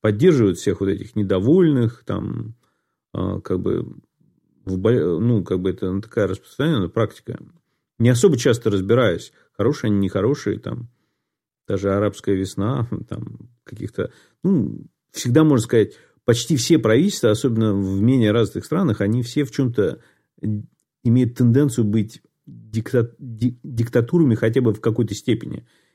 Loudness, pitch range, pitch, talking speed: -20 LUFS, 105-130 Hz, 115 Hz, 125 wpm